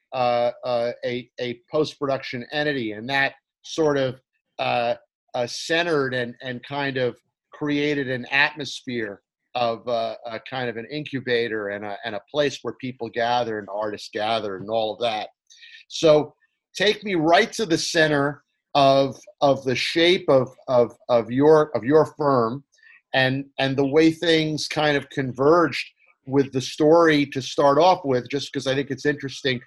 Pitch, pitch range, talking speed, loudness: 135 Hz, 120-150 Hz, 165 wpm, -22 LUFS